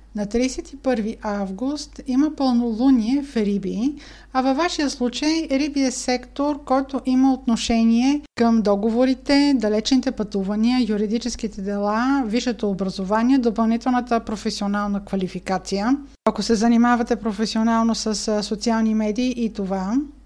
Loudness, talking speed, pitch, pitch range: -21 LUFS, 110 wpm, 235 Hz, 215-265 Hz